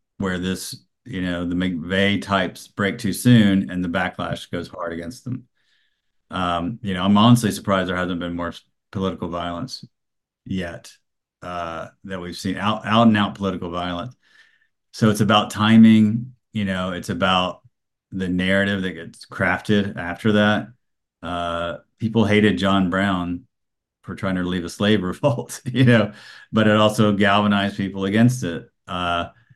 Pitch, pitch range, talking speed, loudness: 95 Hz, 90-105 Hz, 155 wpm, -20 LUFS